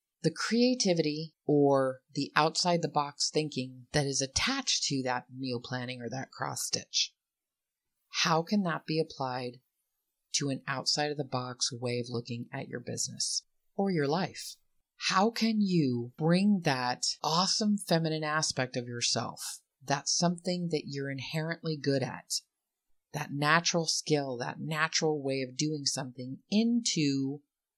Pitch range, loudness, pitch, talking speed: 130-165 Hz, -30 LUFS, 150 Hz, 145 wpm